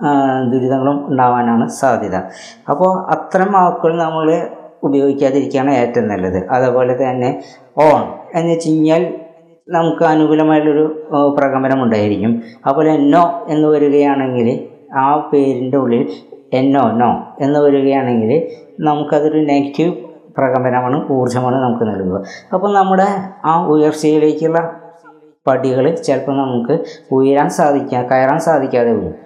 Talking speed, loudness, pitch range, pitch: 100 wpm, -14 LUFS, 130-160 Hz, 145 Hz